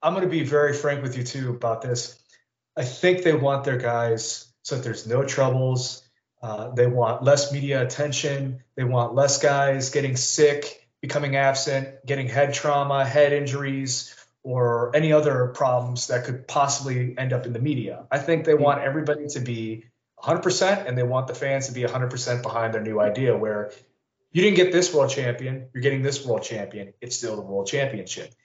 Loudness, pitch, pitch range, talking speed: -23 LUFS, 130 Hz, 120-145 Hz, 190 wpm